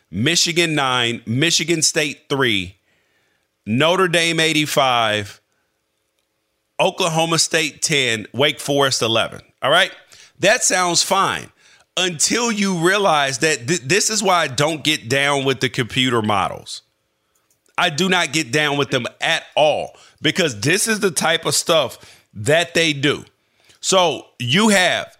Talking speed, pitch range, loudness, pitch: 135 wpm, 120-170 Hz, -17 LUFS, 150 Hz